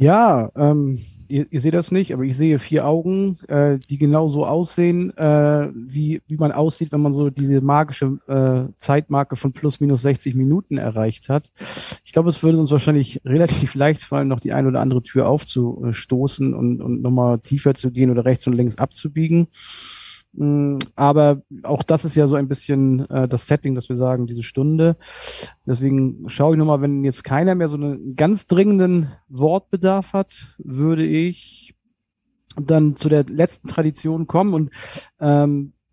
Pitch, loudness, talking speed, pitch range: 145 Hz, -19 LUFS, 170 wpm, 135-160 Hz